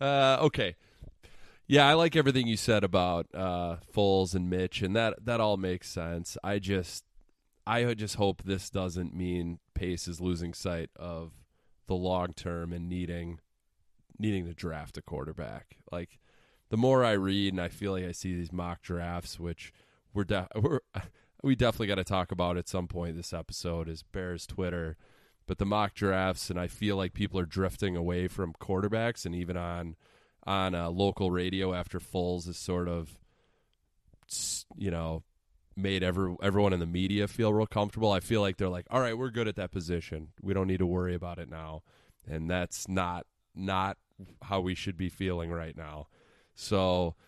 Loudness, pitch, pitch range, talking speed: -31 LUFS, 90 Hz, 85-100 Hz, 180 wpm